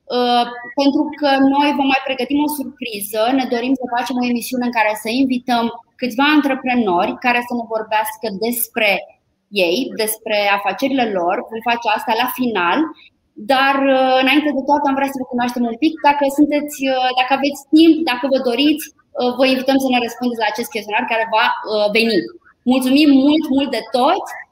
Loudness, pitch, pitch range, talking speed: -17 LUFS, 250 Hz, 230-275 Hz, 170 wpm